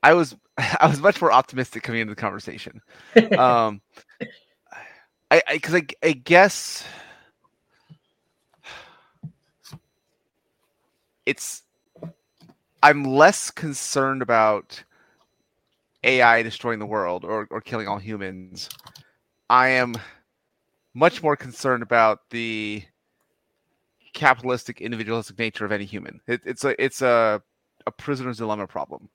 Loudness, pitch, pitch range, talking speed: -21 LUFS, 120 Hz, 110-135 Hz, 110 wpm